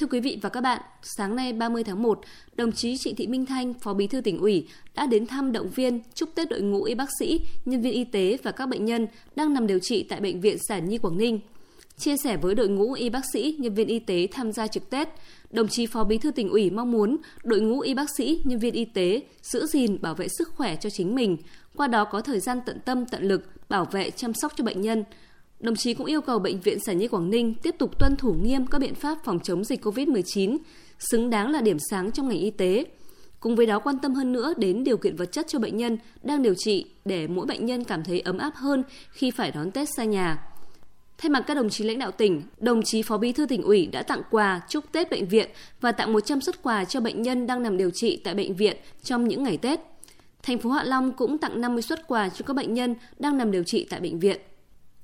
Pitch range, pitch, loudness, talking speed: 210-270 Hz, 235 Hz, -26 LUFS, 260 wpm